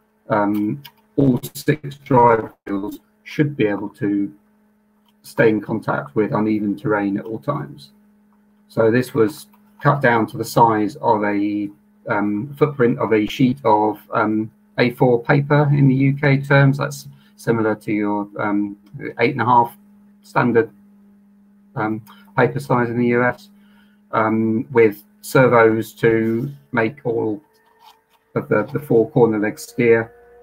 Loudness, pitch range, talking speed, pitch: -19 LUFS, 110-150 Hz, 140 wpm, 120 Hz